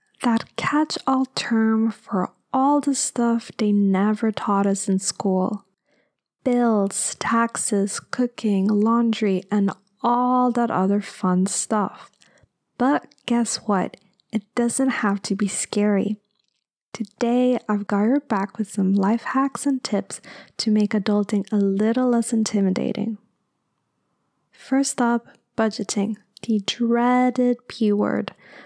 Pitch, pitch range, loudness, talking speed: 215 Hz, 200-240 Hz, -22 LUFS, 120 wpm